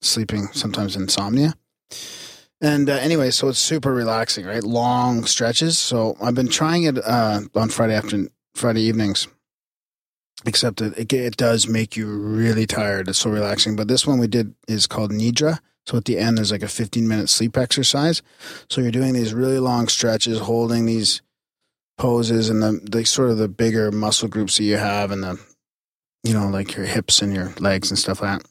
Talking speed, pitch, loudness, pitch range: 190 wpm, 115 Hz, -20 LUFS, 105-120 Hz